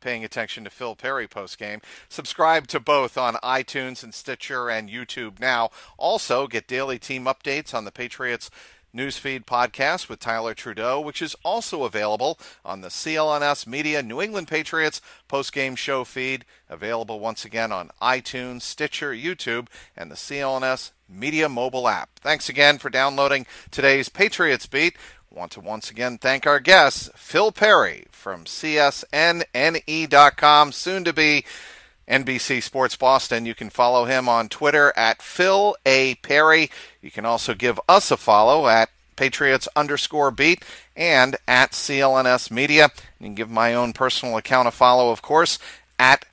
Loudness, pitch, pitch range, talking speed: -20 LUFS, 130 Hz, 120-145 Hz, 155 wpm